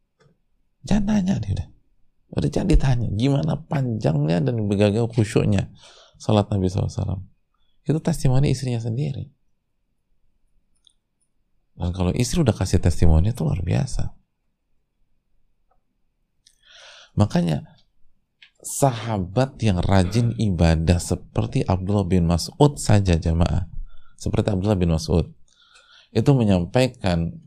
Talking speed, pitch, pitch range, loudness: 100 wpm, 110 Hz, 95-135 Hz, -22 LUFS